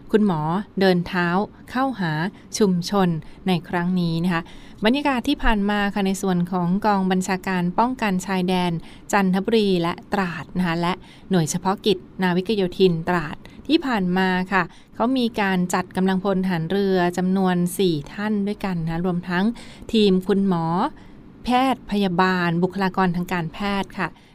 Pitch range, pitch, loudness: 180-205 Hz, 190 Hz, -22 LUFS